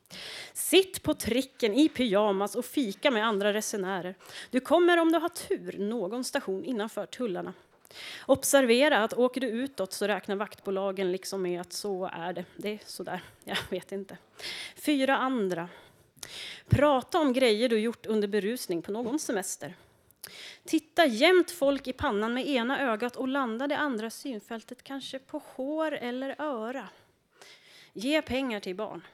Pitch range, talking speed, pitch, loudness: 205-275 Hz, 150 wpm, 245 Hz, -29 LUFS